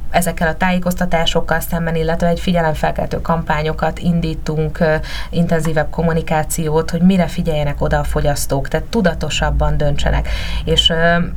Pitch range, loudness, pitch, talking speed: 155-170 Hz, -17 LUFS, 160 Hz, 110 wpm